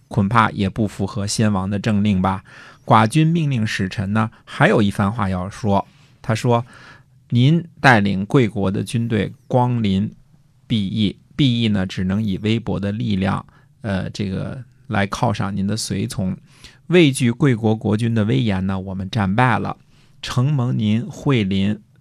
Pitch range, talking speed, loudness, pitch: 100-130 Hz, 220 characters per minute, -19 LUFS, 110 Hz